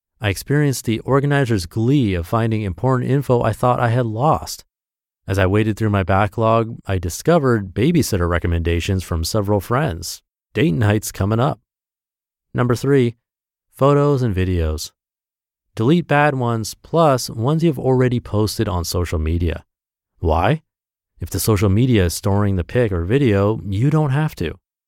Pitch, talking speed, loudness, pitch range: 110 Hz, 150 wpm, -18 LUFS, 95-130 Hz